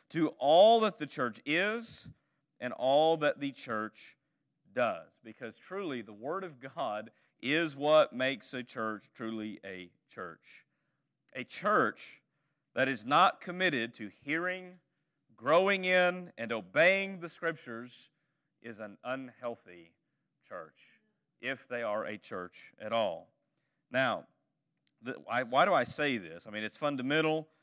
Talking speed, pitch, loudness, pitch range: 135 wpm, 150 Hz, -31 LUFS, 115-170 Hz